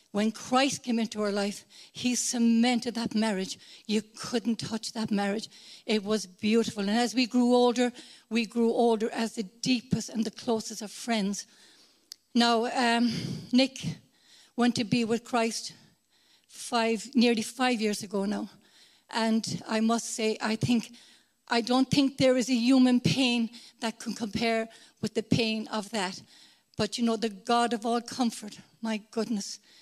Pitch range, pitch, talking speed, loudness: 220-240 Hz, 230 Hz, 160 wpm, -28 LUFS